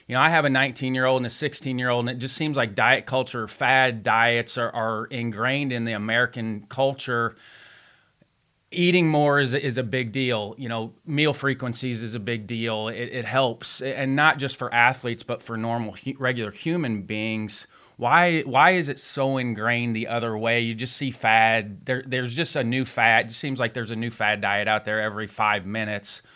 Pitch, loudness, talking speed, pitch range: 120 Hz, -23 LUFS, 200 wpm, 115-135 Hz